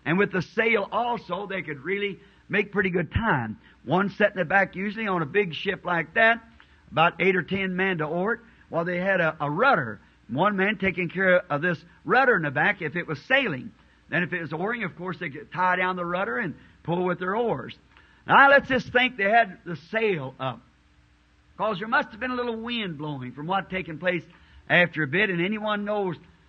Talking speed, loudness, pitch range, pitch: 225 wpm, -24 LUFS, 165-205 Hz, 185 Hz